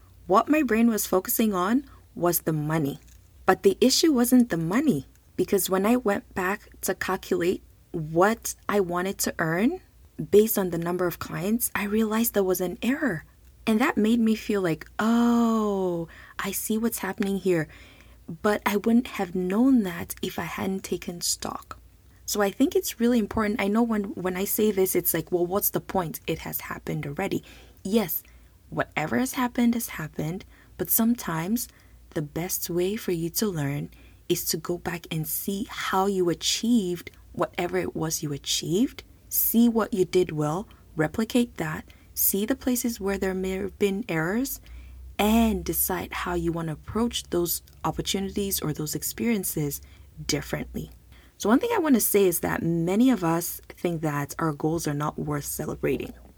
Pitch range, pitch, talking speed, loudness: 170-225 Hz, 195 Hz, 175 wpm, -26 LUFS